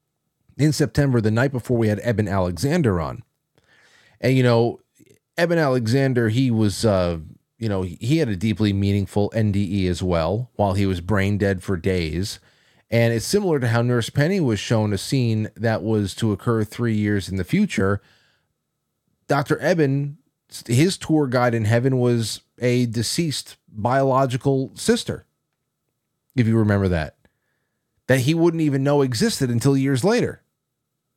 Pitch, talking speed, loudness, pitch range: 115 Hz, 155 wpm, -21 LUFS, 105-140 Hz